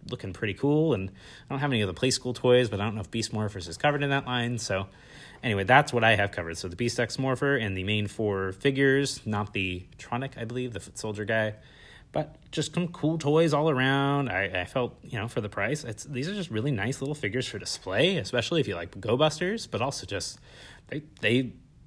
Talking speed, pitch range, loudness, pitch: 240 wpm, 105-140 Hz, -28 LUFS, 120 Hz